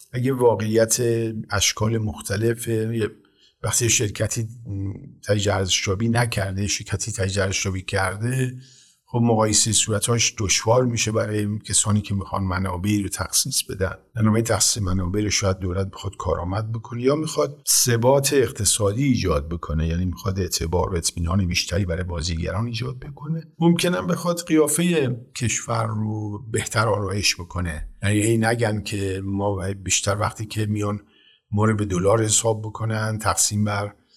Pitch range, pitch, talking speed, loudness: 95-115 Hz, 105 Hz, 130 wpm, -22 LUFS